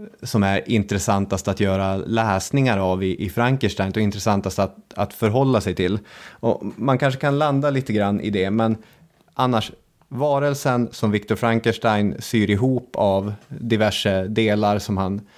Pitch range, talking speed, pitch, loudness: 100-125 Hz, 150 wpm, 110 Hz, -21 LUFS